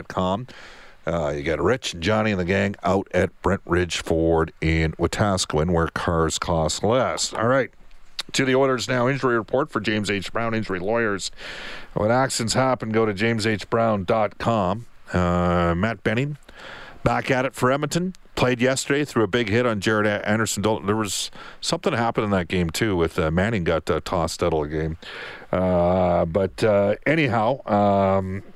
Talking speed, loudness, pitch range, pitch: 170 wpm, -22 LUFS, 90-115 Hz, 105 Hz